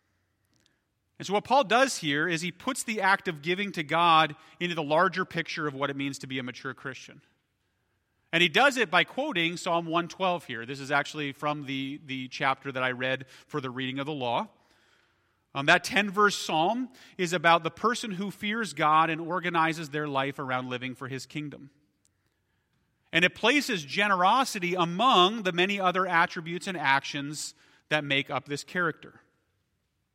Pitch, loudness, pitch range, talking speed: 155 Hz, -27 LUFS, 135-180 Hz, 180 wpm